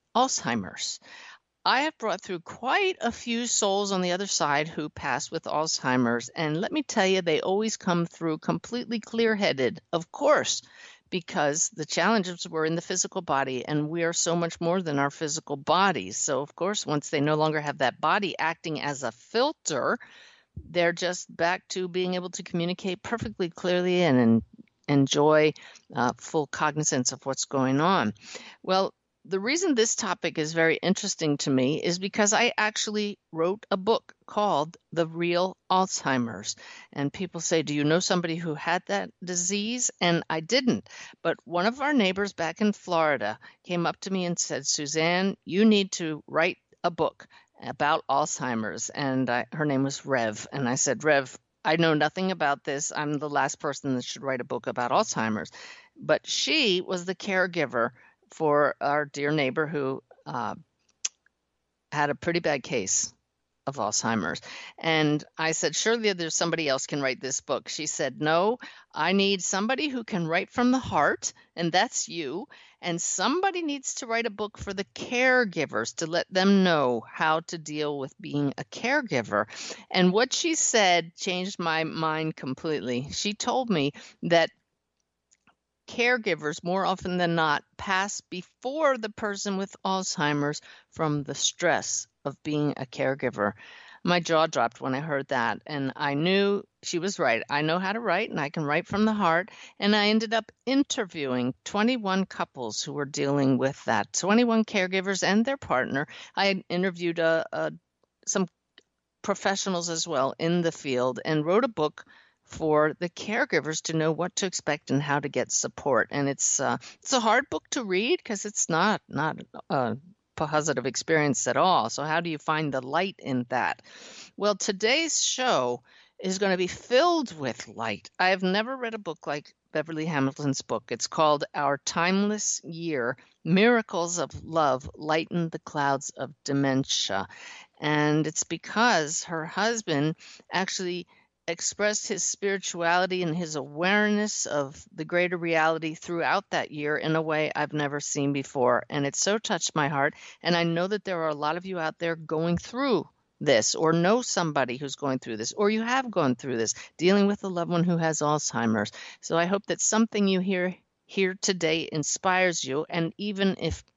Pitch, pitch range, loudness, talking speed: 170 Hz, 150-195 Hz, -27 LUFS, 175 wpm